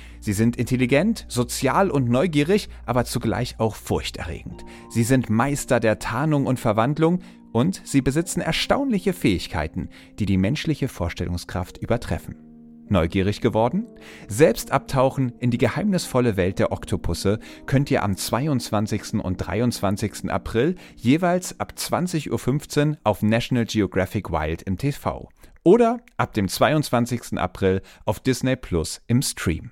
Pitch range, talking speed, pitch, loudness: 95-135 Hz, 130 wpm, 115 Hz, -23 LUFS